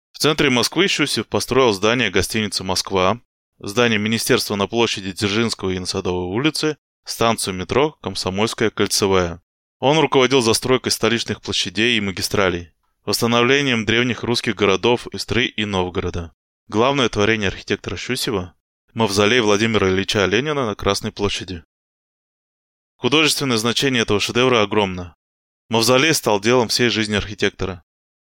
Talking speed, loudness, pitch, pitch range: 120 wpm, -18 LUFS, 105 Hz, 95-120 Hz